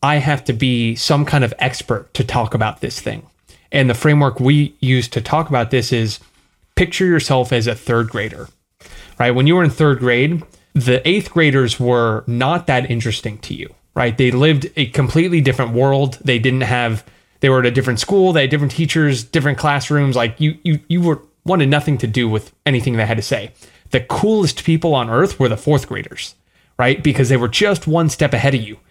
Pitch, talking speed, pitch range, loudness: 135 Hz, 210 wpm, 120-150 Hz, -16 LUFS